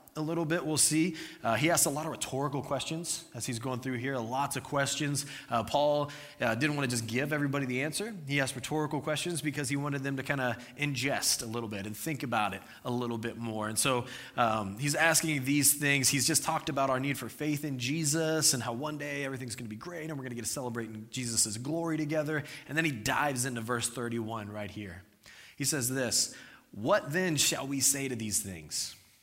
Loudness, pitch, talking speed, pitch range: -31 LUFS, 140 Hz, 230 wpm, 120-150 Hz